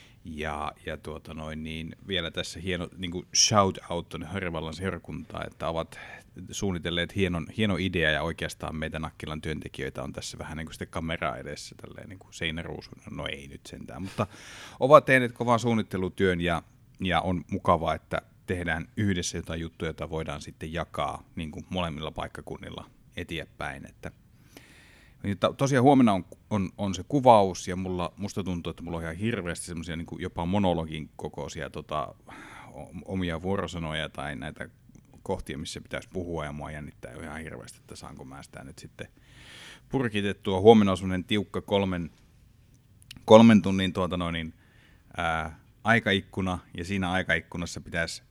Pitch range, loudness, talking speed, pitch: 80-100 Hz, -28 LUFS, 145 wpm, 90 Hz